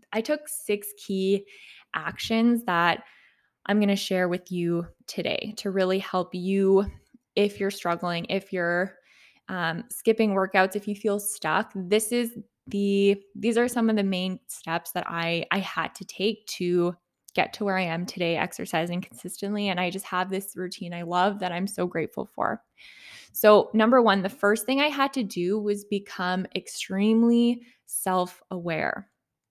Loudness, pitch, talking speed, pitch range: -26 LUFS, 195 Hz, 165 wpm, 180-215 Hz